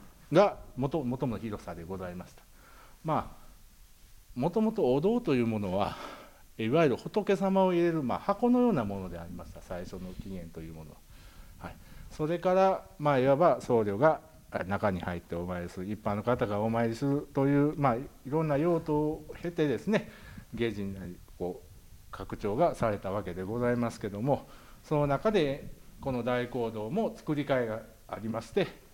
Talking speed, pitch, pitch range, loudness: 320 characters per minute, 115 Hz, 95-145 Hz, -30 LUFS